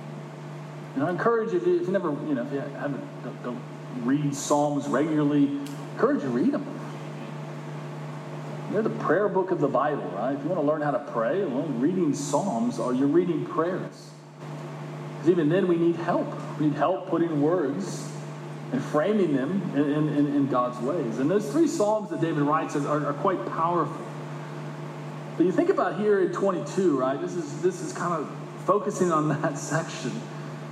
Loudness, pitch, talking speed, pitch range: -26 LUFS, 155 Hz, 185 wpm, 145-180 Hz